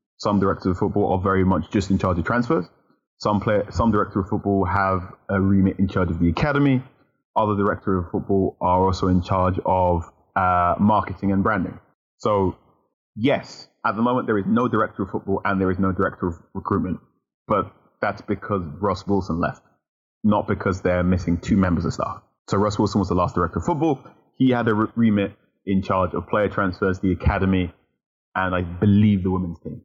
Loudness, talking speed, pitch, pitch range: -22 LUFS, 195 wpm, 95 Hz, 95-105 Hz